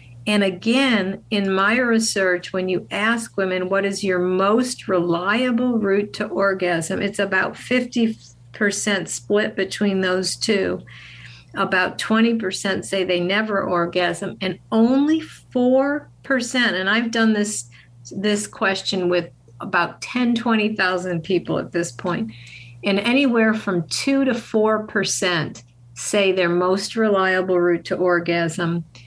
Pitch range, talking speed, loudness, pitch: 175-220 Hz, 125 wpm, -20 LUFS, 195 Hz